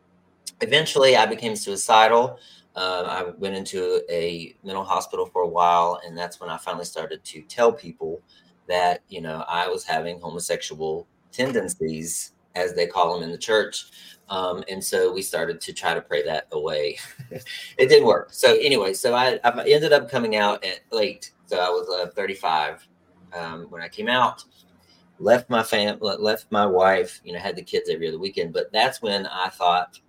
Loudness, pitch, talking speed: -22 LUFS, 140 Hz, 185 wpm